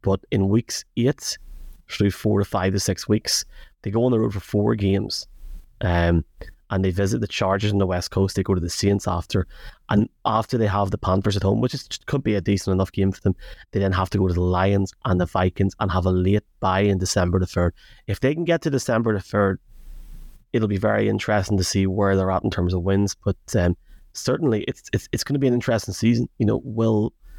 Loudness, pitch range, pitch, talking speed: -22 LUFS, 95-105 Hz, 100 Hz, 240 wpm